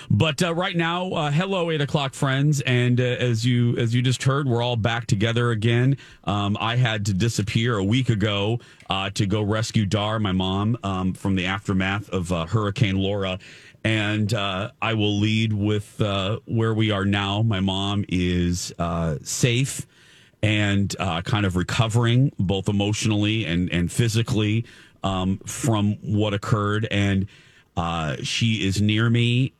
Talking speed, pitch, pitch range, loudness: 165 wpm, 110 Hz, 100-120 Hz, -23 LUFS